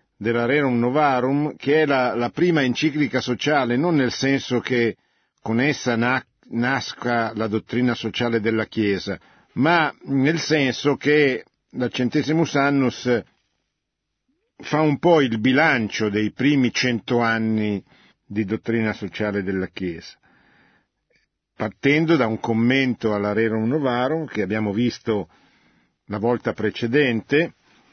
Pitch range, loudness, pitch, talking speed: 110-140 Hz, -21 LUFS, 120 Hz, 120 wpm